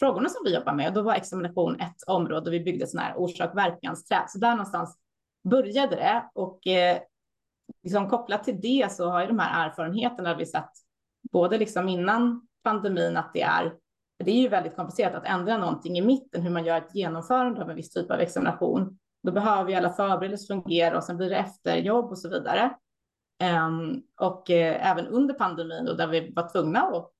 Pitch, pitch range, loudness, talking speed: 185 Hz, 175-225 Hz, -26 LUFS, 200 wpm